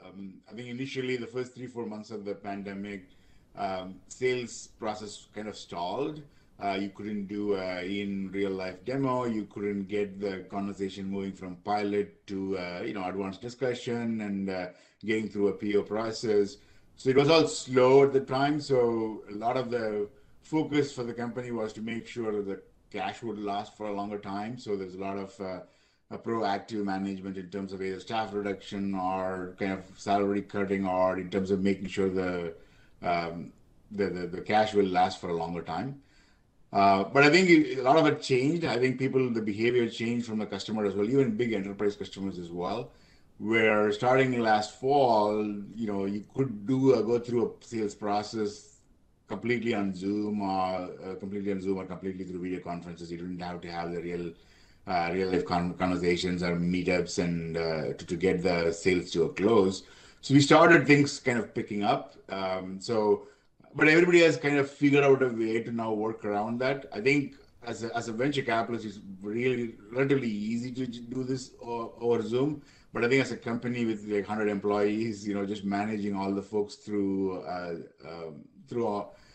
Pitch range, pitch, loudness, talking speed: 95-120 Hz, 105 Hz, -29 LUFS, 195 wpm